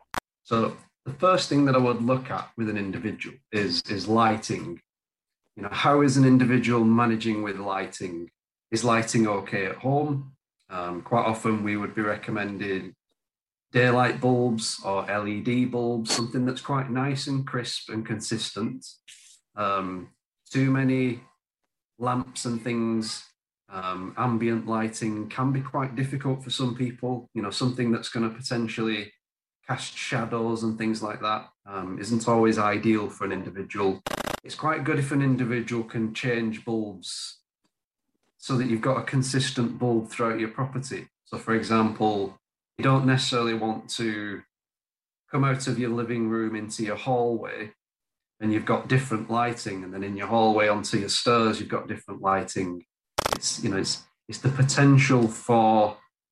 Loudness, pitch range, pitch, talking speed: -26 LUFS, 105-125 Hz, 115 Hz, 155 wpm